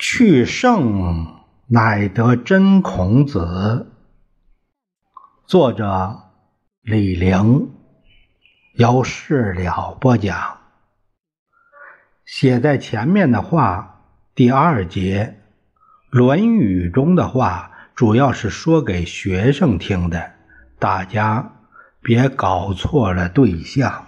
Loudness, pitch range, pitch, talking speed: -17 LUFS, 95-140 Hz, 115 Hz, 115 characters per minute